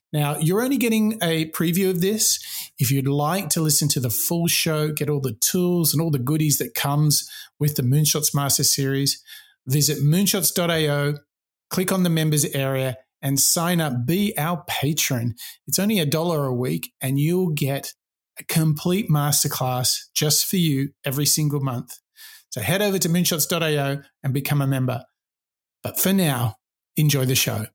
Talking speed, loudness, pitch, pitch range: 170 wpm, -21 LUFS, 150 Hz, 140-170 Hz